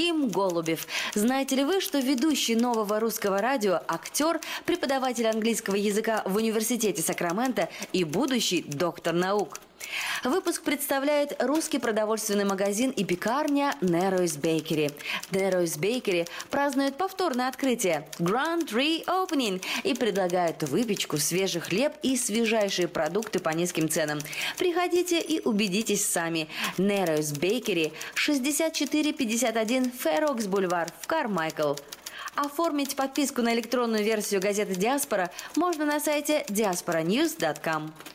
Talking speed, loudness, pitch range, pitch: 110 wpm, -27 LUFS, 180-285 Hz, 220 Hz